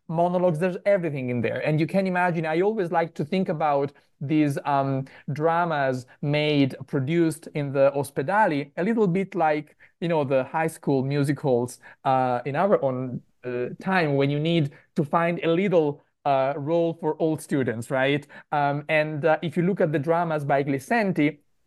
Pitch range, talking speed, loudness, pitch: 140-170 Hz, 175 wpm, -24 LUFS, 155 Hz